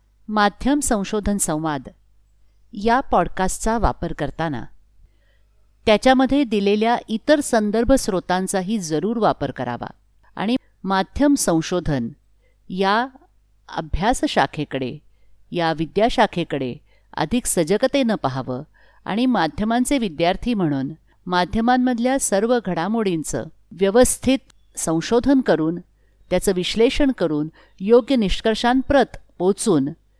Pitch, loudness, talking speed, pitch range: 195 Hz, -20 LUFS, 80 wpm, 155-240 Hz